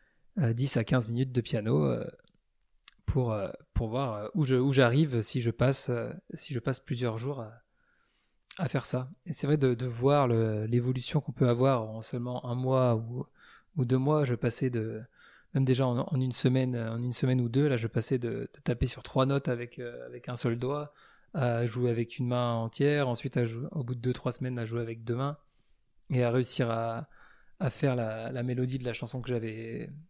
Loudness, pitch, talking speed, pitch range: -30 LUFS, 125 Hz, 210 wpm, 120-135 Hz